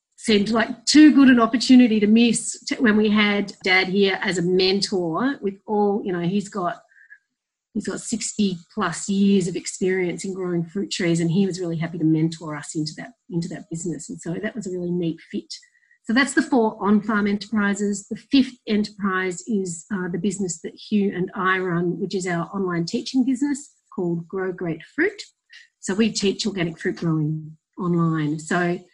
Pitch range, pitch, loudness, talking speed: 175-225 Hz, 195 Hz, -22 LUFS, 190 wpm